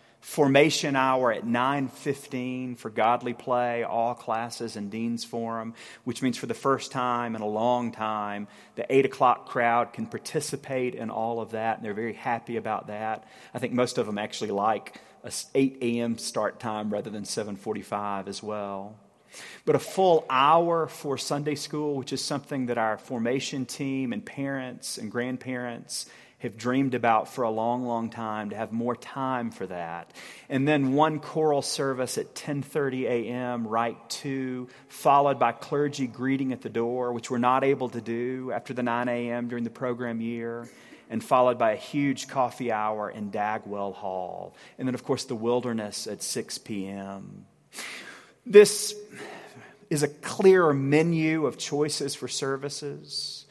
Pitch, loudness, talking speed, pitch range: 125 Hz, -27 LUFS, 165 wpm, 115-135 Hz